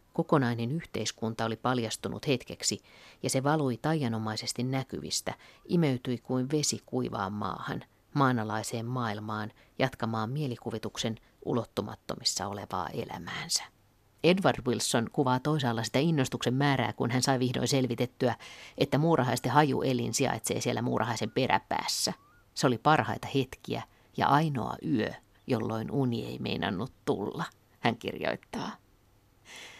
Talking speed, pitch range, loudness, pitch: 115 wpm, 115-135 Hz, -30 LUFS, 125 Hz